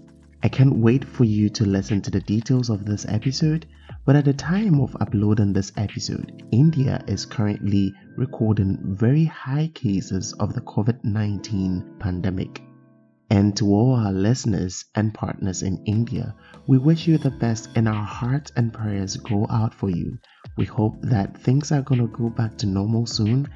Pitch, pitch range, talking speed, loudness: 110 Hz, 100-130 Hz, 175 wpm, -22 LUFS